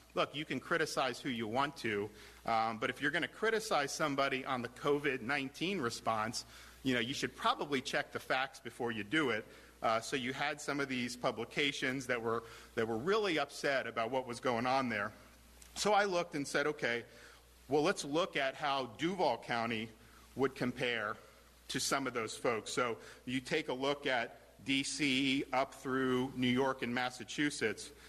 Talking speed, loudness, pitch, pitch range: 180 wpm, -36 LUFS, 130 Hz, 115-145 Hz